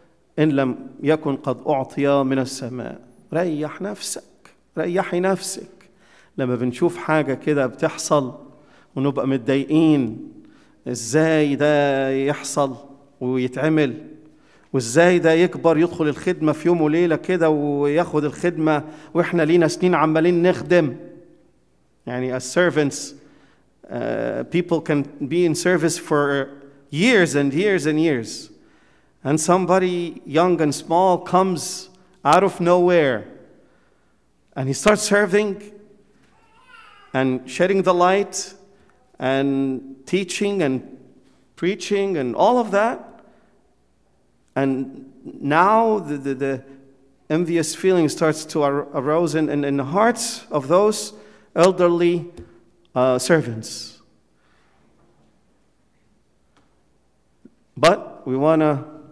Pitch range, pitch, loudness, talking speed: 140-180 Hz, 160 Hz, -20 LUFS, 105 wpm